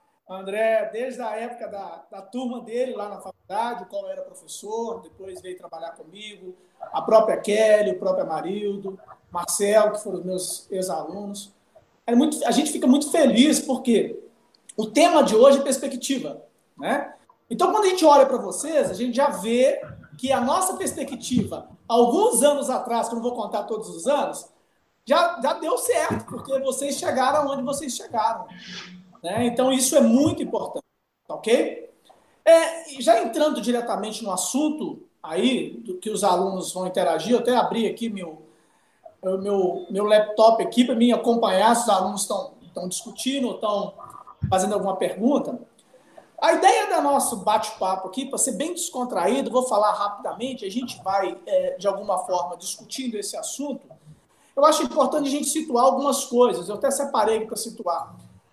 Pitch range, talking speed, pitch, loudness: 200-280 Hz, 165 wpm, 235 Hz, -22 LUFS